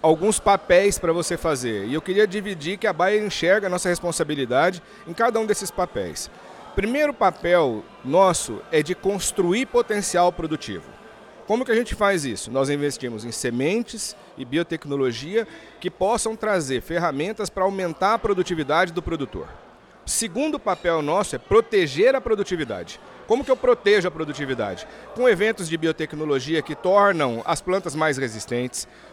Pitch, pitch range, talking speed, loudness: 180 Hz, 155-210 Hz, 150 wpm, -22 LUFS